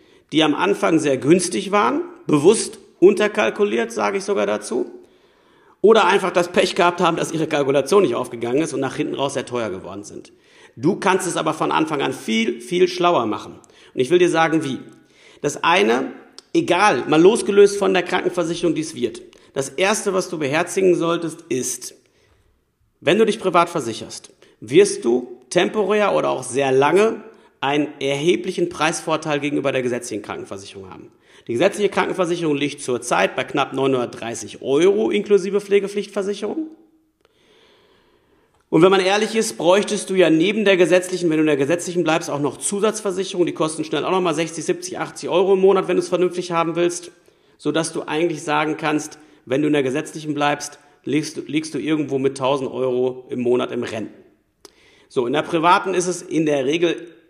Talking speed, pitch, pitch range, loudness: 175 wpm, 175 Hz, 150-205 Hz, -19 LUFS